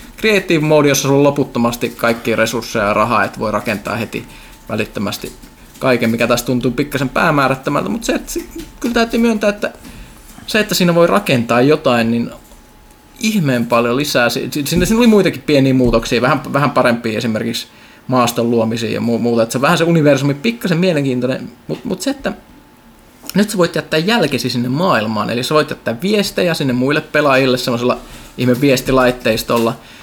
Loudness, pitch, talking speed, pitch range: -15 LUFS, 135 Hz, 165 wpm, 120-170 Hz